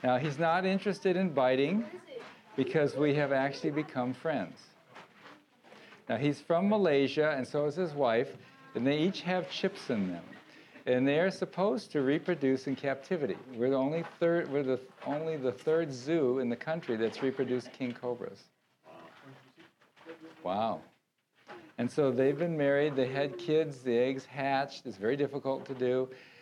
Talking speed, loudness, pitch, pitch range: 160 wpm, -32 LUFS, 140 Hz, 130-165 Hz